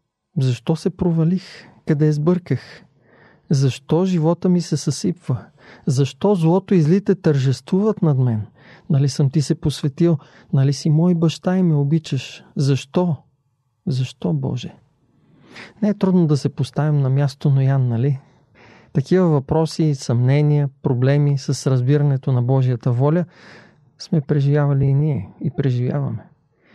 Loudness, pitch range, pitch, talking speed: -19 LUFS, 135-165 Hz, 145 Hz, 130 wpm